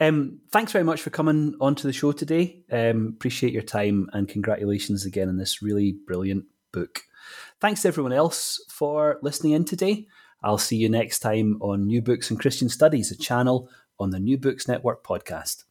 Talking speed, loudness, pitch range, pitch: 185 wpm, -24 LUFS, 105-150 Hz, 125 Hz